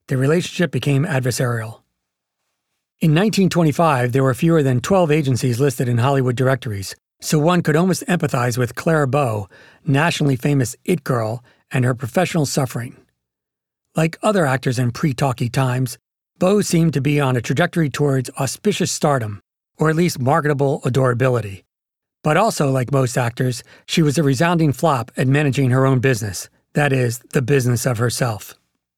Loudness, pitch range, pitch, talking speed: -18 LUFS, 125-160 Hz, 135 Hz, 150 wpm